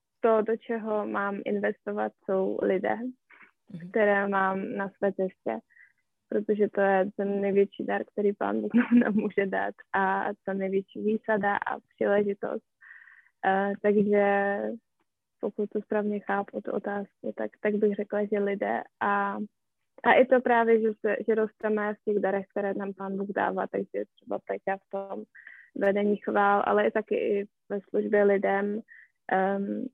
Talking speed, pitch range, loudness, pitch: 150 wpm, 195-215 Hz, -28 LUFS, 200 Hz